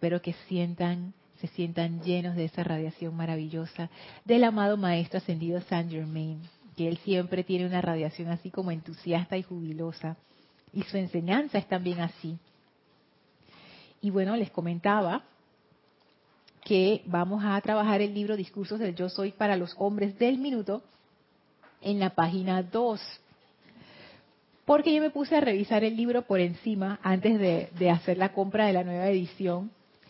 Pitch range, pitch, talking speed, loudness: 170-205 Hz, 185 Hz, 150 wpm, -29 LUFS